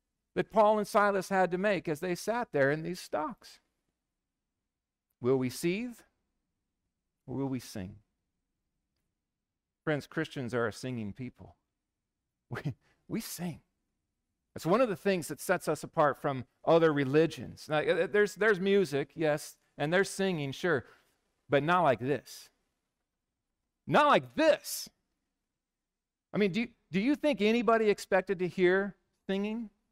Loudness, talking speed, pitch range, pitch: -30 LUFS, 140 wpm, 130-200 Hz, 165 Hz